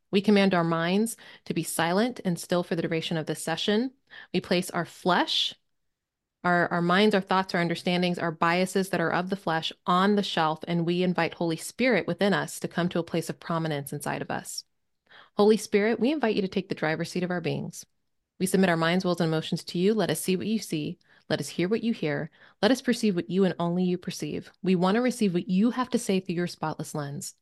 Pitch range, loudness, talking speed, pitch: 165-200 Hz, -27 LUFS, 240 wpm, 180 Hz